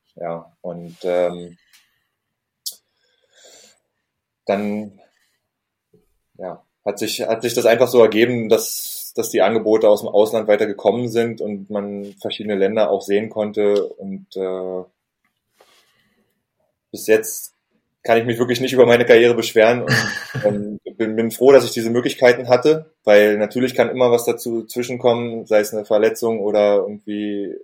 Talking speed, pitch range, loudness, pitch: 140 wpm, 100-120 Hz, -17 LUFS, 110 Hz